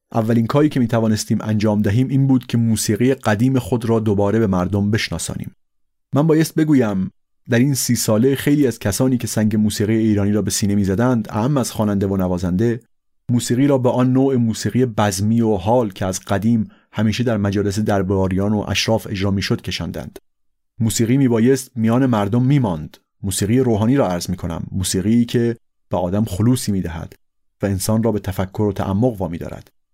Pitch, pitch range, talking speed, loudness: 110 Hz, 100-125 Hz, 185 wpm, -18 LUFS